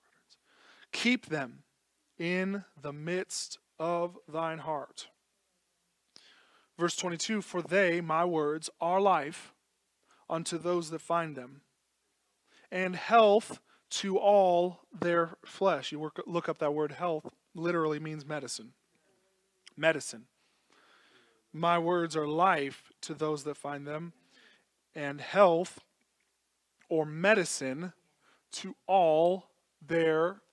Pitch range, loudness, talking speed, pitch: 155-180 Hz, -31 LUFS, 105 wpm, 170 Hz